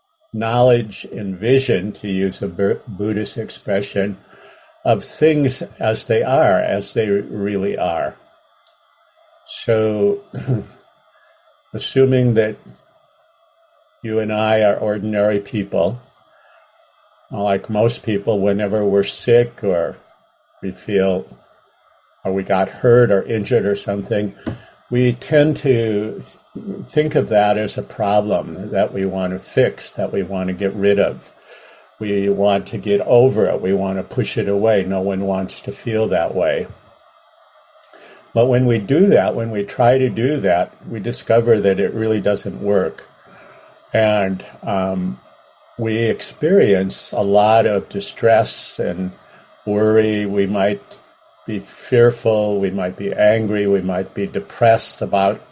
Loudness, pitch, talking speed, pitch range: -18 LUFS, 105 Hz, 135 wpm, 100-115 Hz